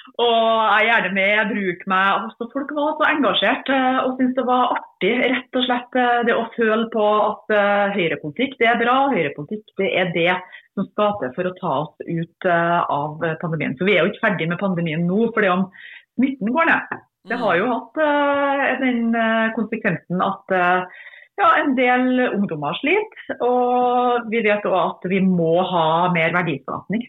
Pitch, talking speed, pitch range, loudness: 220 Hz, 175 wpm, 180-250 Hz, -19 LUFS